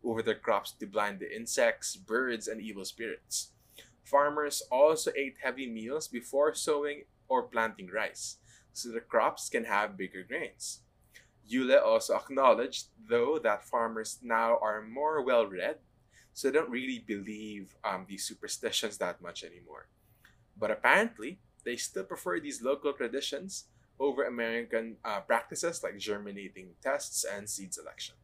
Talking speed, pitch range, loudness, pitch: 145 wpm, 110-145 Hz, -32 LUFS, 120 Hz